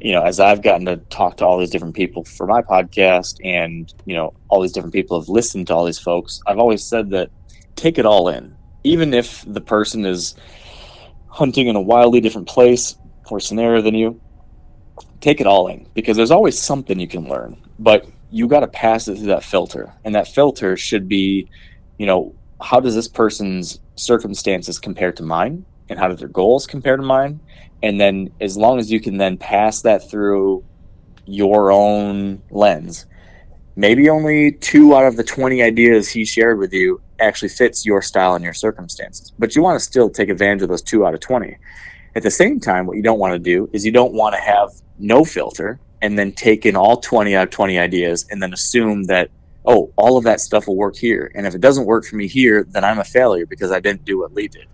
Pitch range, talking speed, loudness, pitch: 95-120 Hz, 215 wpm, -16 LUFS, 105 Hz